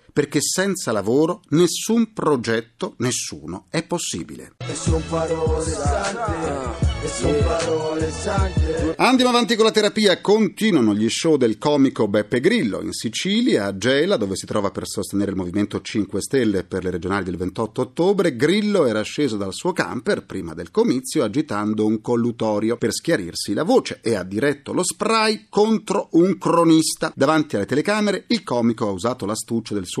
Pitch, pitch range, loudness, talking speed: 135 Hz, 105-175 Hz, -20 LUFS, 145 wpm